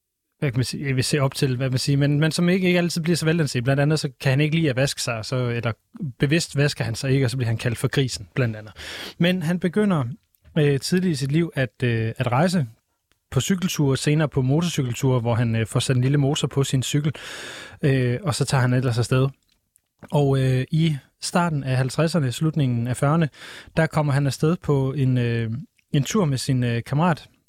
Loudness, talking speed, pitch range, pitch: -22 LUFS, 230 wpm, 125-155 Hz, 140 Hz